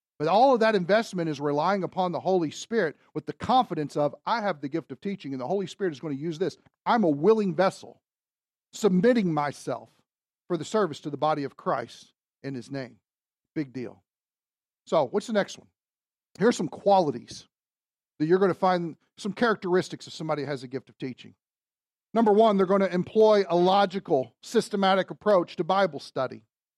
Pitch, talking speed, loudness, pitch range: 180 Hz, 190 wpm, -26 LUFS, 150-205 Hz